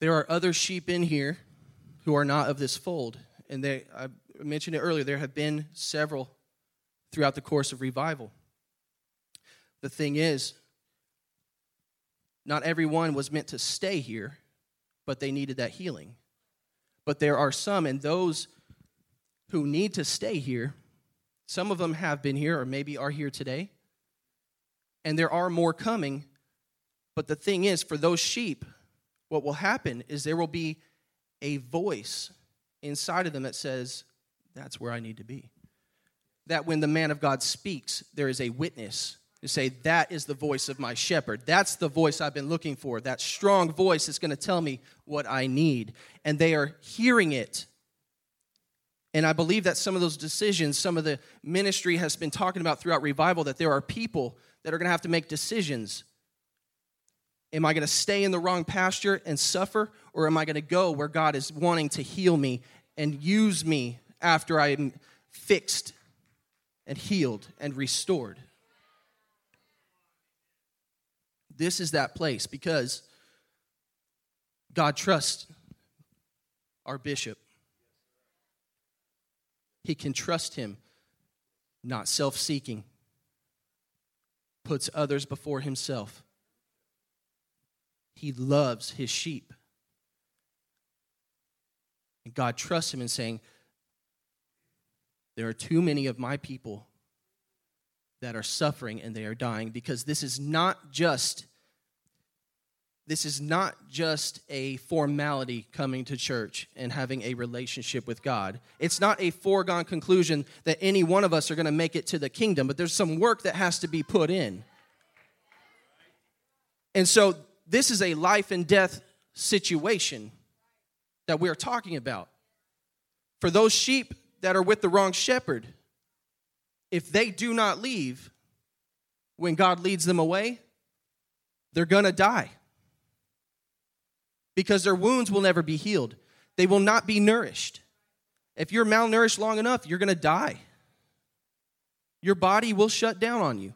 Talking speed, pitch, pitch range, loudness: 150 wpm, 150 Hz, 130-175 Hz, -27 LUFS